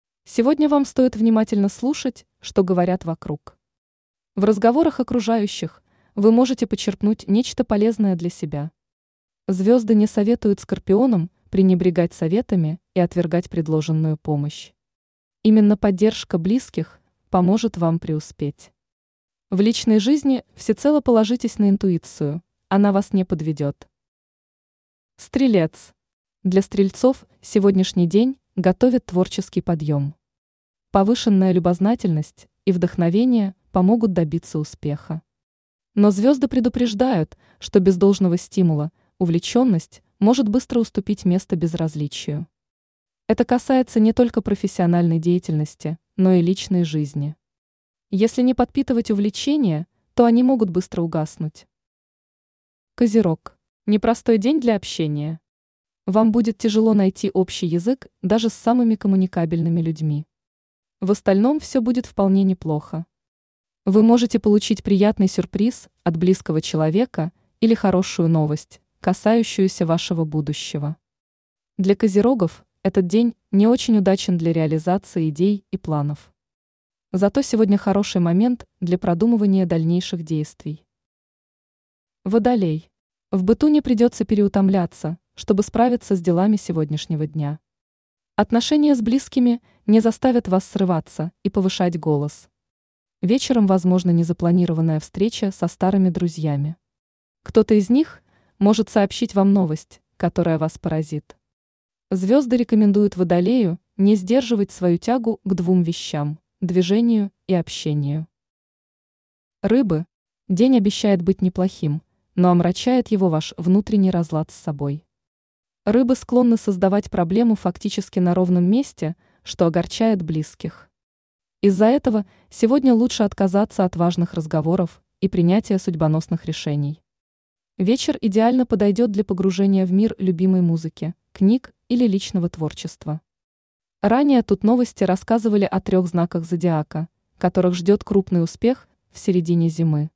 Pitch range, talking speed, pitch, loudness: 170-220 Hz, 115 wpm, 195 Hz, -20 LUFS